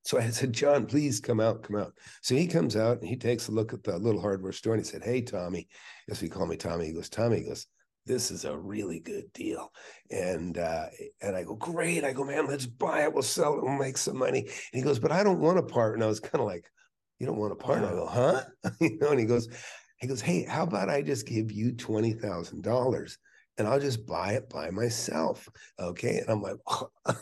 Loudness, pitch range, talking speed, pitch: -30 LUFS, 110-140 Hz, 250 wpm, 120 Hz